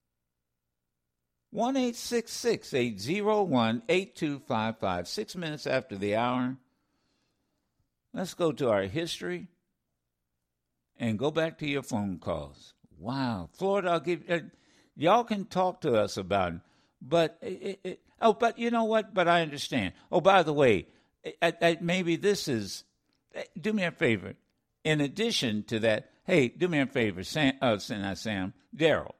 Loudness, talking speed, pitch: -29 LUFS, 145 wpm, 150 Hz